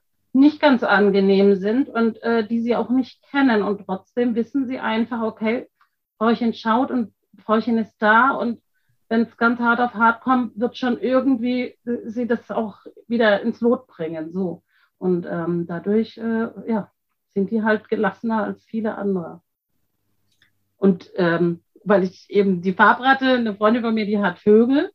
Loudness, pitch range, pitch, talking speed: -20 LUFS, 200-240 Hz, 225 Hz, 165 wpm